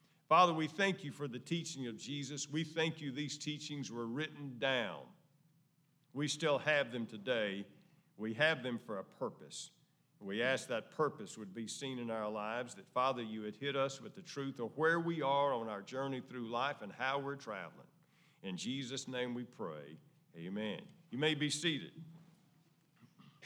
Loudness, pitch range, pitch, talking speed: -38 LUFS, 120-160 Hz, 140 Hz, 180 wpm